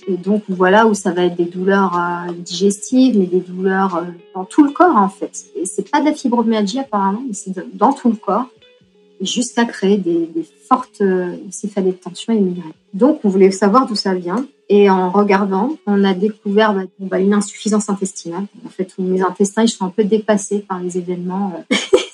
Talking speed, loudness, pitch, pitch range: 210 wpm, -16 LUFS, 200 Hz, 185-220 Hz